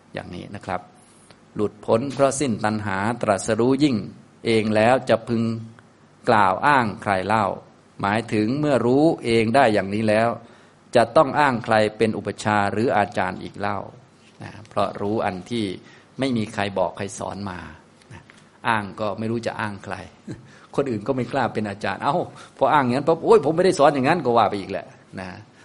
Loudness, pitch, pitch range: -21 LUFS, 110 Hz, 100-125 Hz